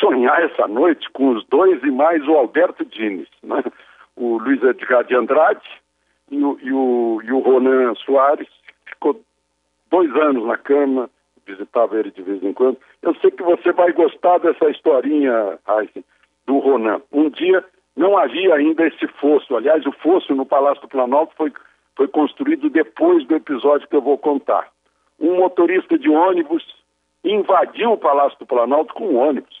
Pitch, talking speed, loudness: 150 Hz, 165 wpm, -17 LUFS